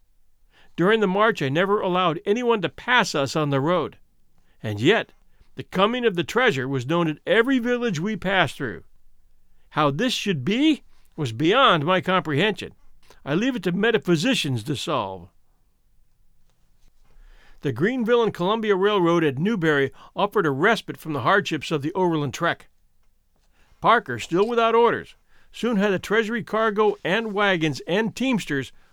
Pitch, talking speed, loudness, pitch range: 185 Hz, 150 wpm, -22 LUFS, 150-220 Hz